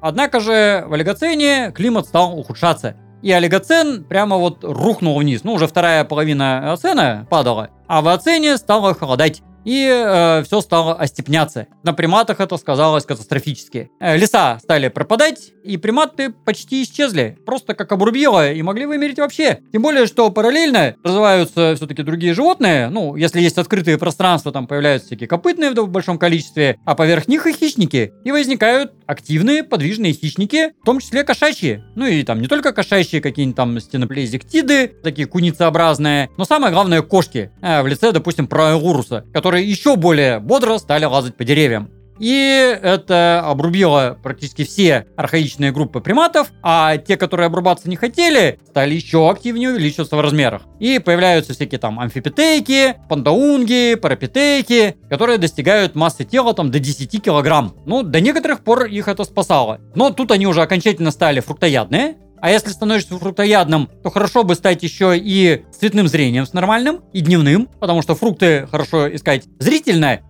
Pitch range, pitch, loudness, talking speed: 150-230 Hz, 175 Hz, -15 LUFS, 155 wpm